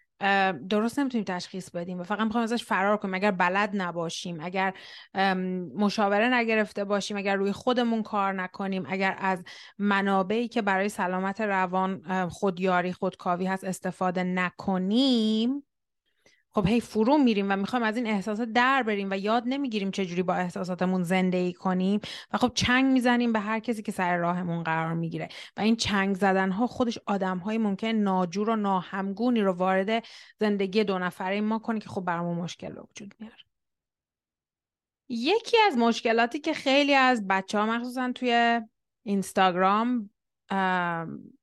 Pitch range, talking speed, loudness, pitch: 185-230 Hz, 150 wpm, -26 LUFS, 200 Hz